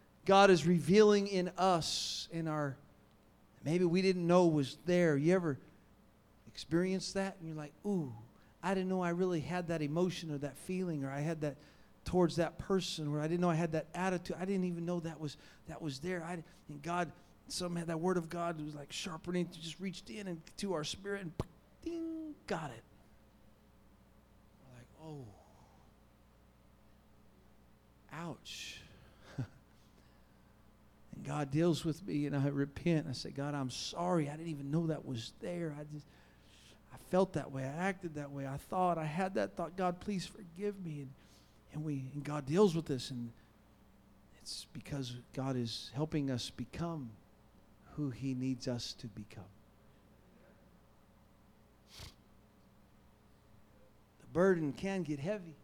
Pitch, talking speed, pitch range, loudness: 155 Hz, 160 wpm, 130-180 Hz, -36 LUFS